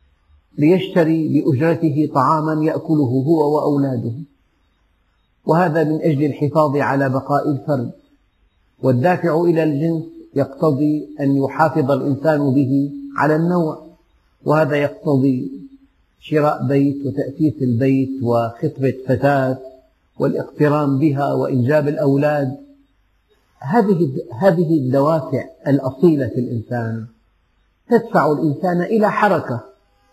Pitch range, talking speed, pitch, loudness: 130-160 Hz, 90 wpm, 145 Hz, -18 LUFS